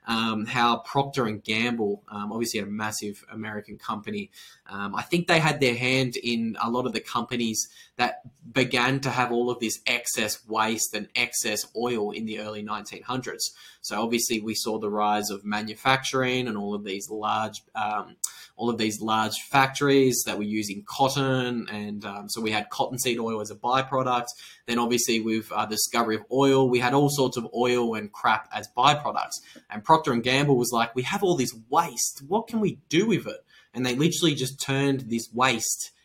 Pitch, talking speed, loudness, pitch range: 120 Hz, 190 wpm, -26 LUFS, 110-130 Hz